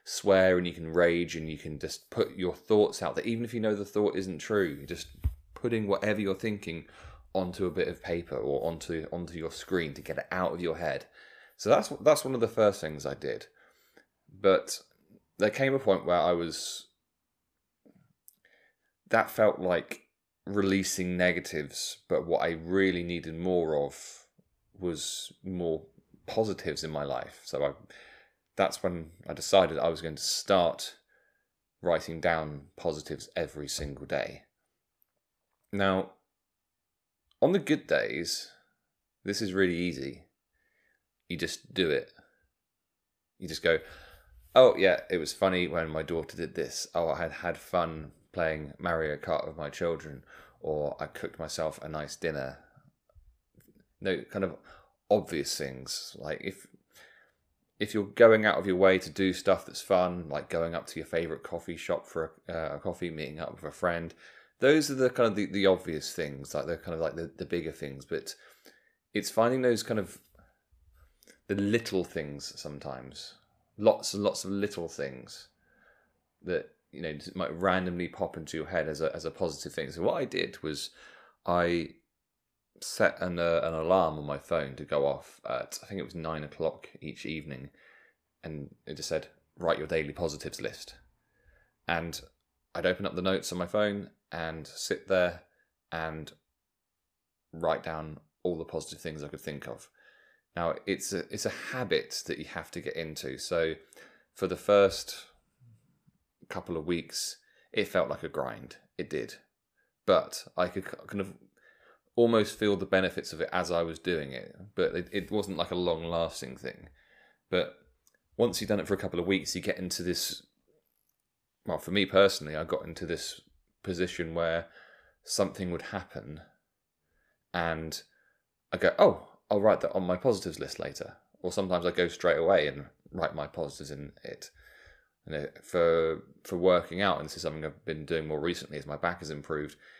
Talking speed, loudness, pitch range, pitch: 175 wpm, -31 LUFS, 80-95 Hz, 85 Hz